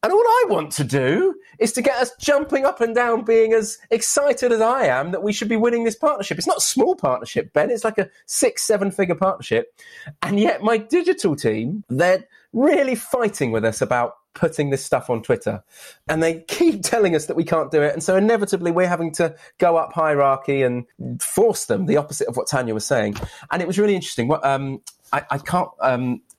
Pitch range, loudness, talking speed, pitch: 150-235 Hz, -20 LUFS, 220 wpm, 195 Hz